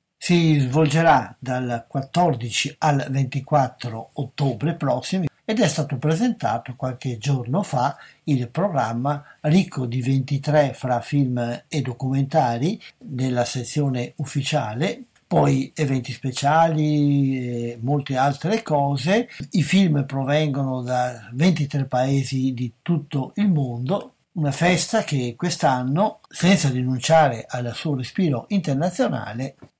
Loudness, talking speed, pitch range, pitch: -22 LUFS, 110 wpm, 130-160 Hz, 140 Hz